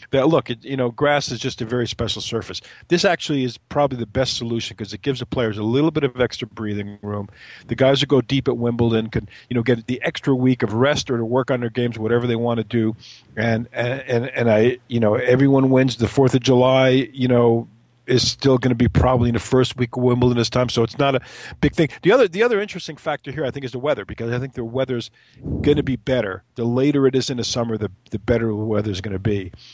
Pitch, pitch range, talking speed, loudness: 125 Hz, 115-130 Hz, 260 wpm, -20 LUFS